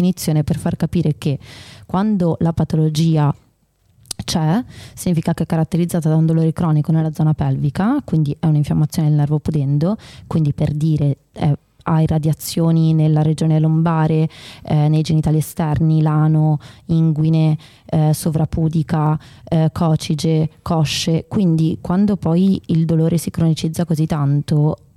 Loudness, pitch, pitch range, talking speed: -17 LUFS, 160 Hz, 150-165 Hz, 130 wpm